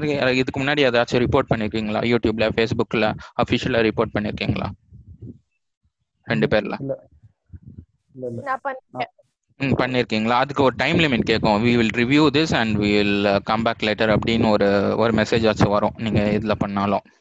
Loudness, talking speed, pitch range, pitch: -20 LUFS, 125 wpm, 105-130 Hz, 115 Hz